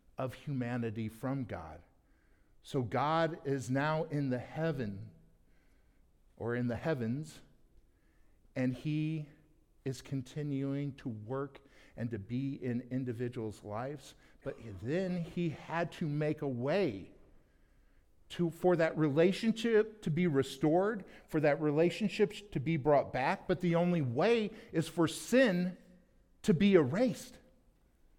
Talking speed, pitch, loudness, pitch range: 125 wpm, 145 Hz, -34 LUFS, 120-170 Hz